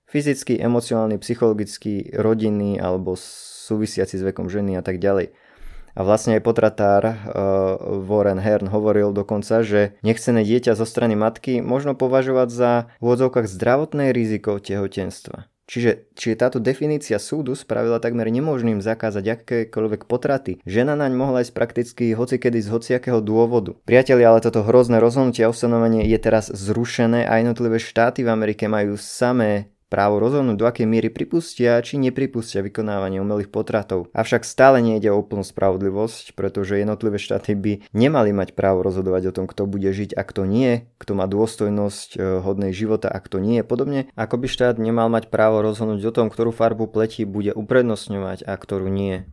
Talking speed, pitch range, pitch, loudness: 160 wpm, 100-120 Hz, 110 Hz, -20 LUFS